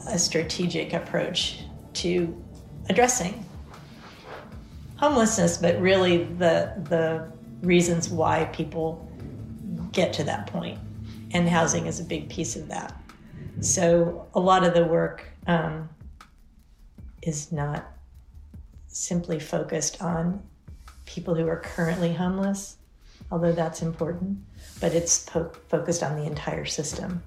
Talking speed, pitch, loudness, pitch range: 115 wpm, 165 Hz, -25 LUFS, 155-175 Hz